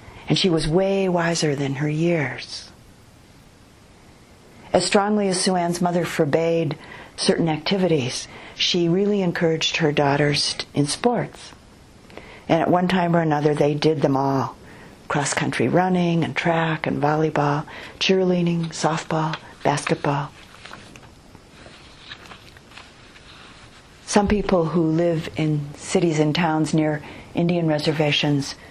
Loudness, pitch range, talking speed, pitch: -21 LUFS, 150-175 Hz, 115 wpm, 160 Hz